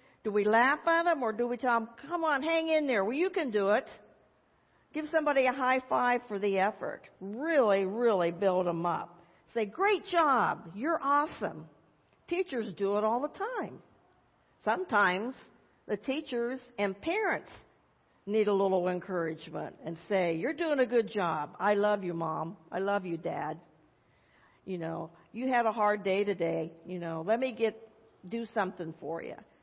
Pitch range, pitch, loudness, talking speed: 185-260 Hz, 215 Hz, -31 LUFS, 170 wpm